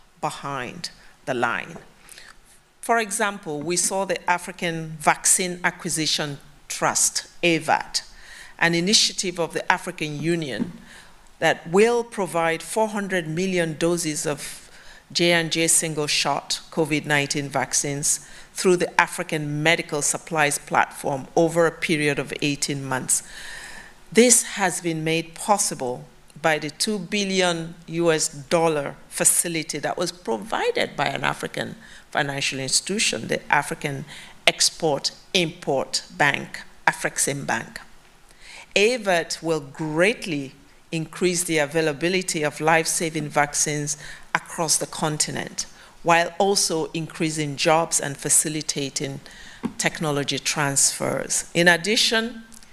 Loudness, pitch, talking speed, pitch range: -22 LUFS, 165 Hz, 105 wpm, 150-180 Hz